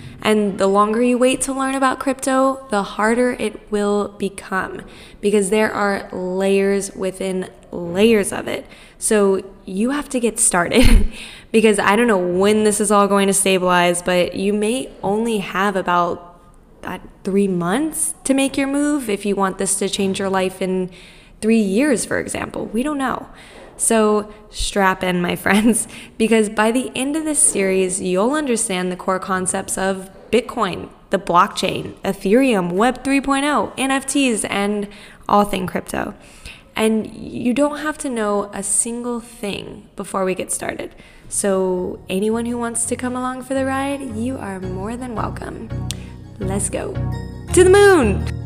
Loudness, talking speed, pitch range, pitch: -18 LUFS, 160 wpm, 195-245 Hz, 210 Hz